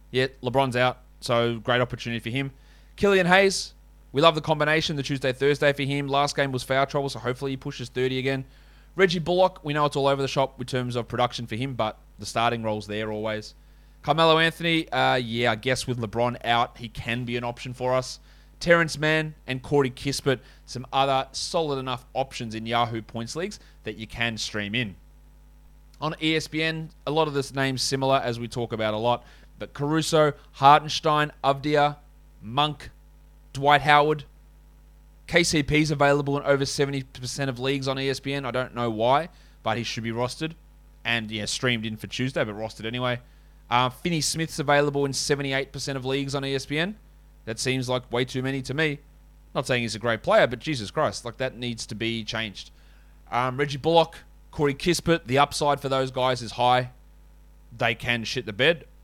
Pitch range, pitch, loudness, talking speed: 120-145 Hz, 135 Hz, -25 LUFS, 185 wpm